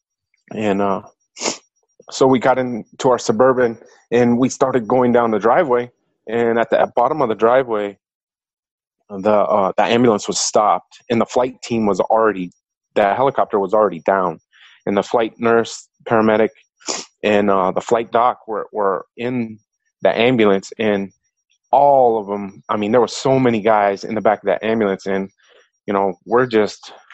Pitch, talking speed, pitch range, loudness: 110 Hz, 170 wpm, 100-120 Hz, -17 LUFS